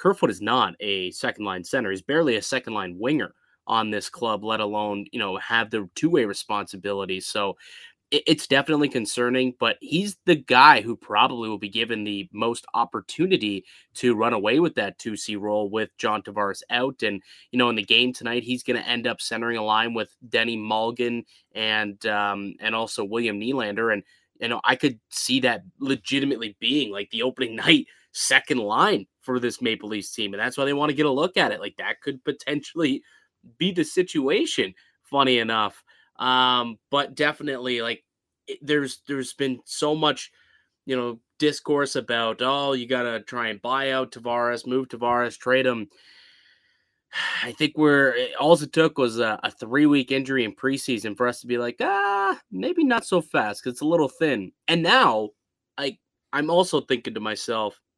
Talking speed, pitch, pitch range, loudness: 185 wpm, 125 Hz, 110-145 Hz, -23 LUFS